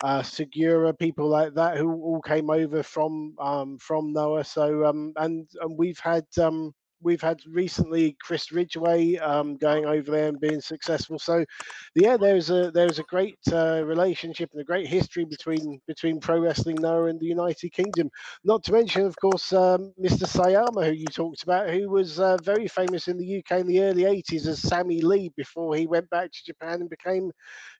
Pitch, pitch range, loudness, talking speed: 165 Hz, 155-180 Hz, -25 LUFS, 195 wpm